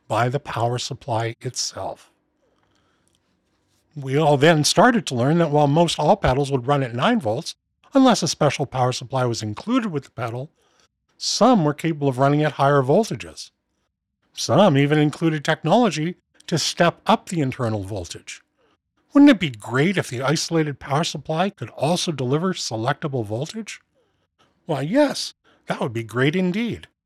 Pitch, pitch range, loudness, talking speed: 145 Hz, 125-170 Hz, -20 LUFS, 155 wpm